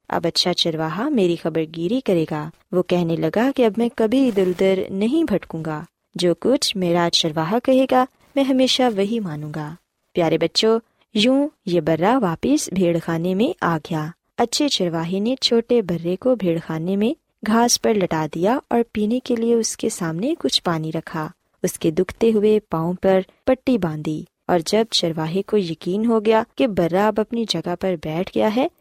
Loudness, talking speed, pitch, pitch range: -20 LUFS, 185 wpm, 190 Hz, 170-235 Hz